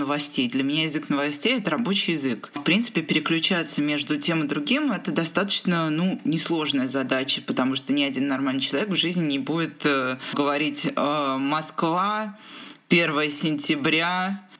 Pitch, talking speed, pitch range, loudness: 160 Hz, 150 wpm, 145-190 Hz, -23 LUFS